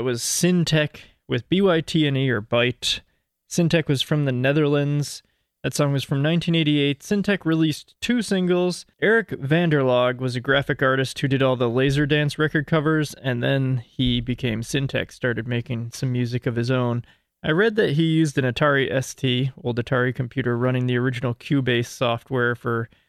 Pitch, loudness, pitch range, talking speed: 135 Hz, -22 LUFS, 125-155 Hz, 165 wpm